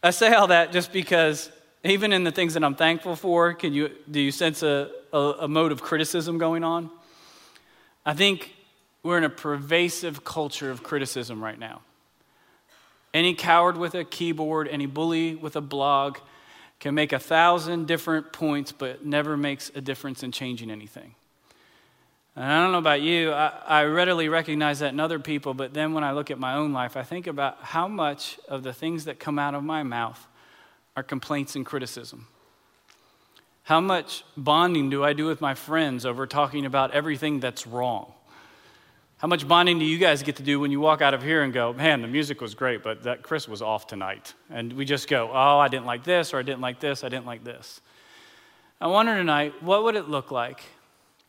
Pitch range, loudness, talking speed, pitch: 140-165 Hz, -24 LUFS, 200 wpm, 150 Hz